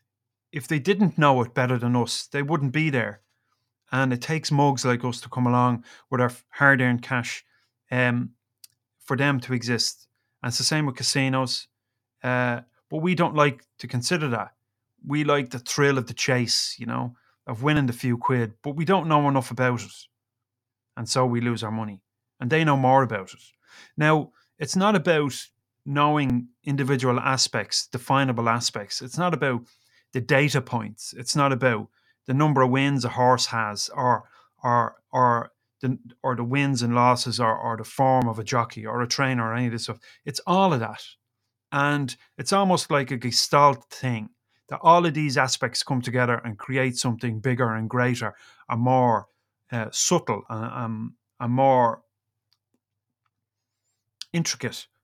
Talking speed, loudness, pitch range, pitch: 175 wpm, -24 LUFS, 115-140 Hz, 125 Hz